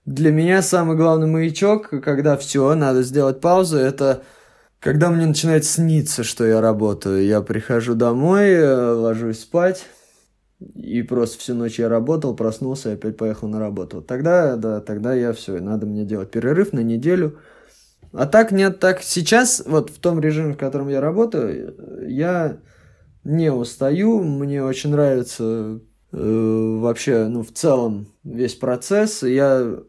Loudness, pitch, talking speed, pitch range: -19 LUFS, 130 Hz, 150 wpm, 115-160 Hz